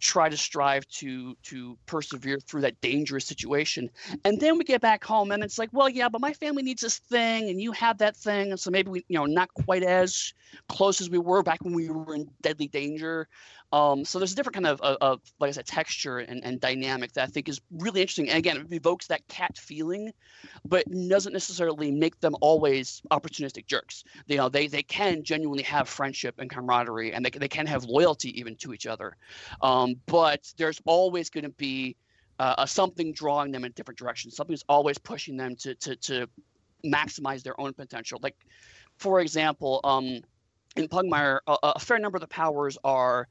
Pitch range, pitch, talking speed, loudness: 135-185 Hz, 150 Hz, 205 wpm, -27 LUFS